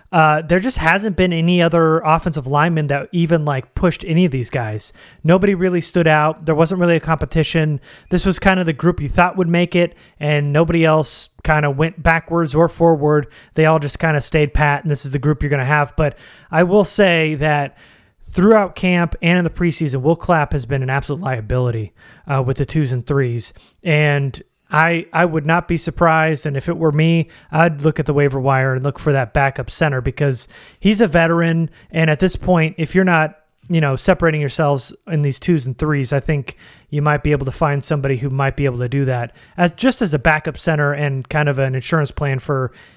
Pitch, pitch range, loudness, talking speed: 155 Hz, 140-170 Hz, -17 LUFS, 220 wpm